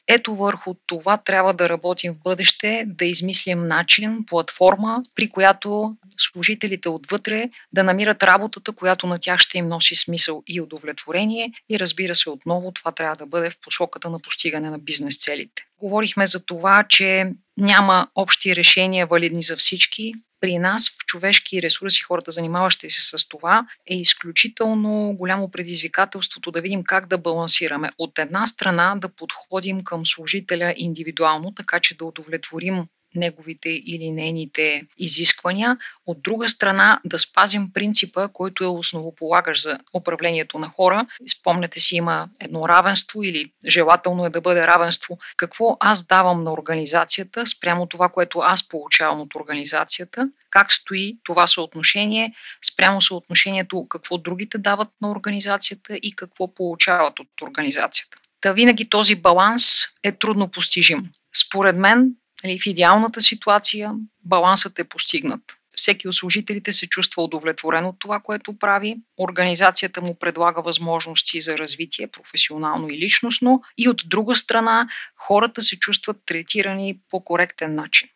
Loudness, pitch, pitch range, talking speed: -16 LUFS, 185 Hz, 170-205 Hz, 140 wpm